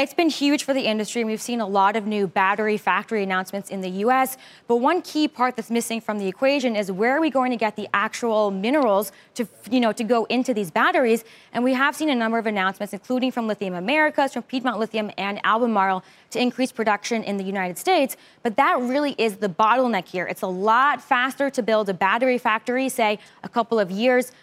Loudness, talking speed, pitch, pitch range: -22 LUFS, 225 wpm, 225 Hz, 205-255 Hz